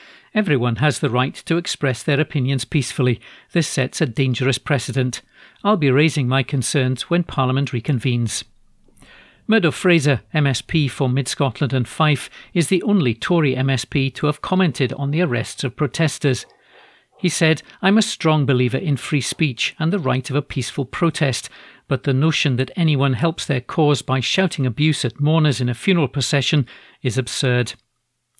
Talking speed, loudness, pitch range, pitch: 165 wpm, -19 LUFS, 130-160 Hz, 140 Hz